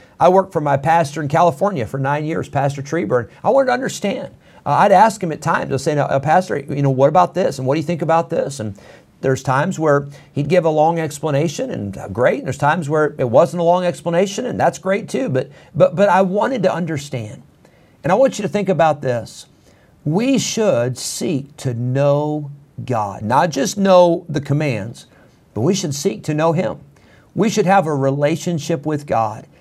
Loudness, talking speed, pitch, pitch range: -17 LUFS, 210 wpm, 155 Hz, 140-175 Hz